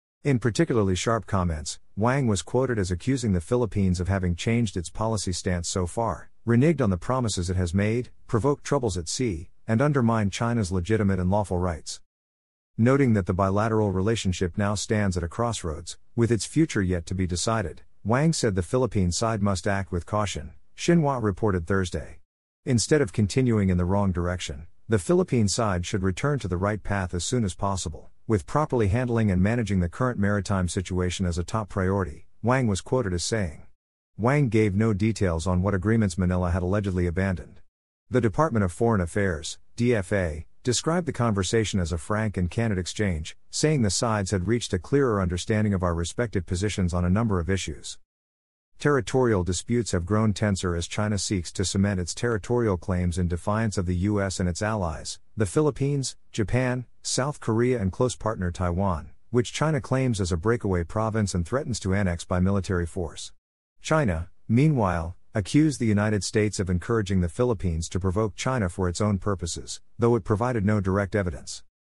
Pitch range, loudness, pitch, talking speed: 90-115 Hz, -25 LUFS, 100 Hz, 180 wpm